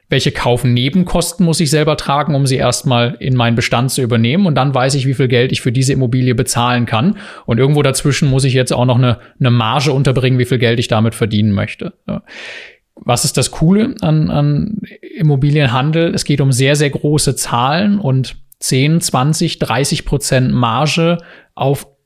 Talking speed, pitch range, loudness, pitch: 180 wpm, 125-155 Hz, -14 LUFS, 135 Hz